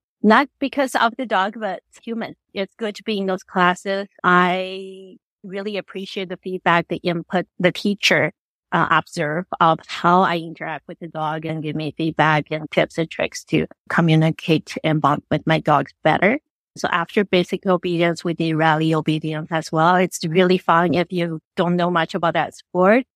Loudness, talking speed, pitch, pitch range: -20 LUFS, 180 wpm, 175 Hz, 160-190 Hz